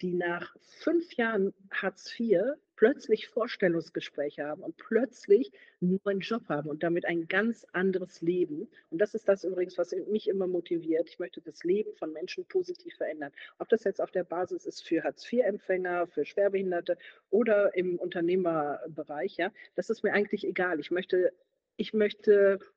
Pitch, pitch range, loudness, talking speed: 195 Hz, 175-230 Hz, -30 LUFS, 165 wpm